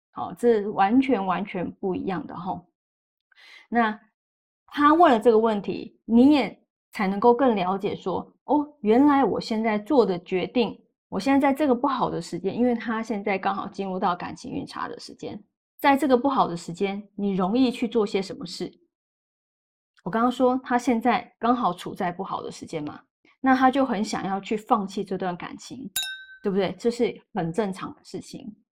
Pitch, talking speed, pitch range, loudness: 230 Hz, 260 characters per minute, 195-255 Hz, -24 LUFS